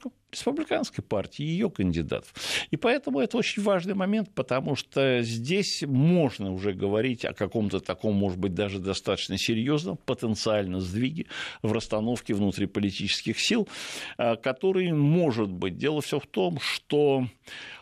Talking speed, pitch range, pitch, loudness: 130 wpm, 105-170 Hz, 125 Hz, -27 LUFS